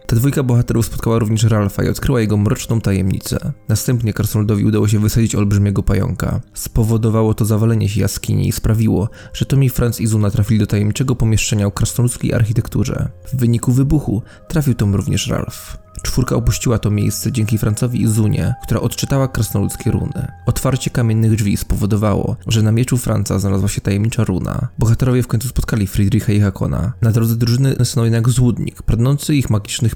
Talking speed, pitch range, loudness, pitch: 170 wpm, 105-125 Hz, -17 LUFS, 115 Hz